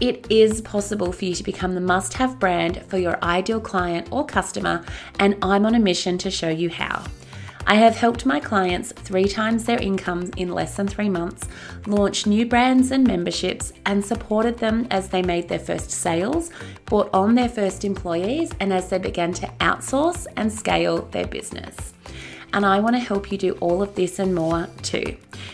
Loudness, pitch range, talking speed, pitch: -22 LUFS, 175-220 Hz, 190 wpm, 195 Hz